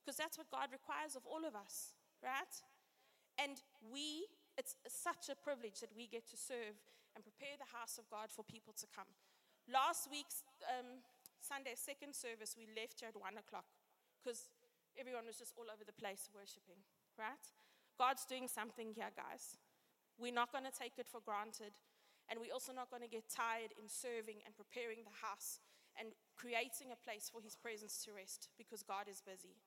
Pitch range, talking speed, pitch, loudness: 215-265 Hz, 190 wpm, 235 Hz, -49 LUFS